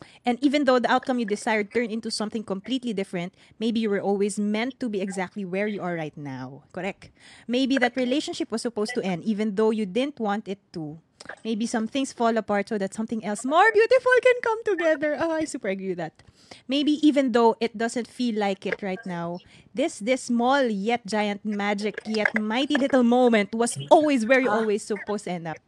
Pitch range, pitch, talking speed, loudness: 200-255 Hz, 225 Hz, 210 wpm, -24 LUFS